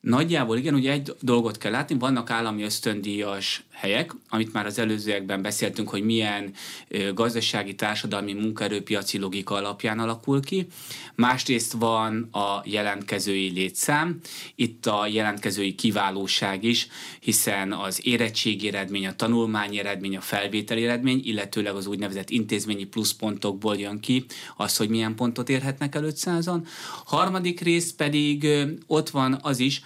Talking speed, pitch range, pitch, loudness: 130 wpm, 100-130 Hz, 110 Hz, -25 LUFS